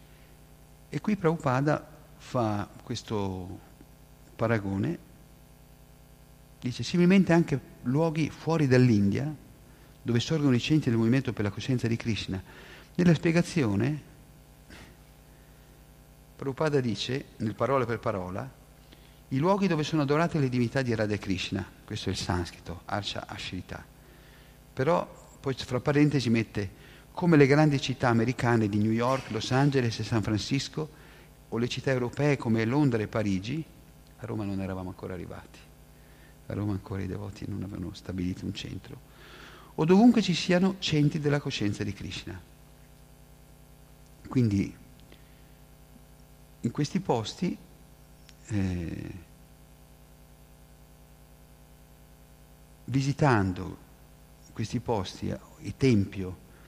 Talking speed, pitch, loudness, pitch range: 115 wpm, 135 Hz, -28 LUFS, 110-145 Hz